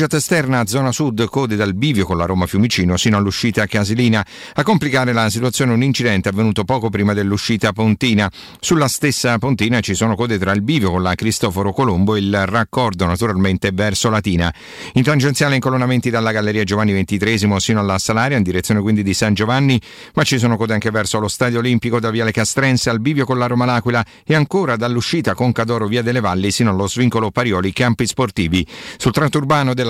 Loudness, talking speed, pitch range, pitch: -16 LUFS, 185 wpm, 105-125 Hz, 115 Hz